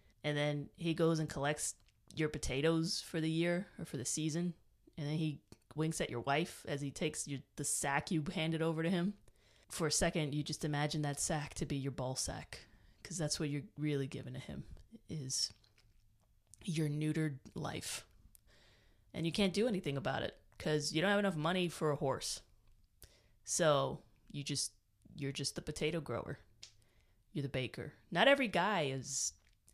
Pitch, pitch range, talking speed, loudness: 145 Hz, 120-160 Hz, 180 wpm, -37 LUFS